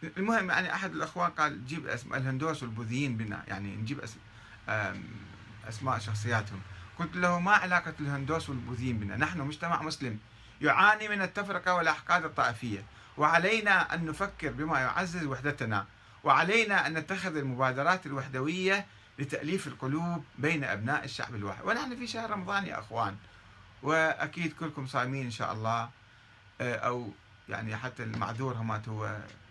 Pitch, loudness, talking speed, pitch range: 135 Hz, -31 LUFS, 130 wpm, 110-165 Hz